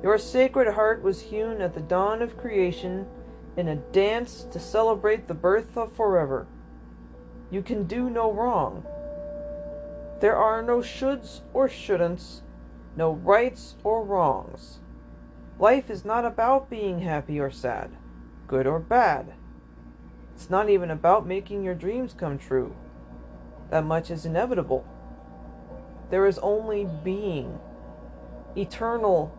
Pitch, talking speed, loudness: 185 Hz, 130 wpm, -25 LUFS